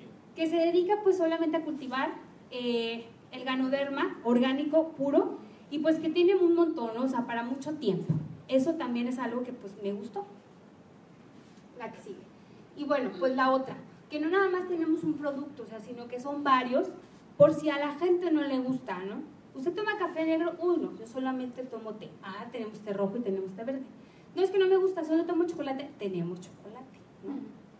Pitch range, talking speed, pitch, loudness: 225-320 Hz, 195 wpm, 260 Hz, -30 LUFS